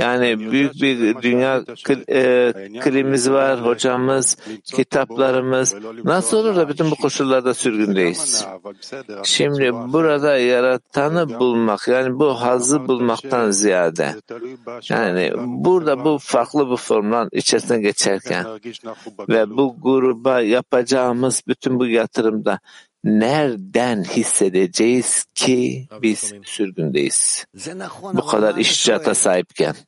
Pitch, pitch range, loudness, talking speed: 125 Hz, 115-135 Hz, -18 LUFS, 100 wpm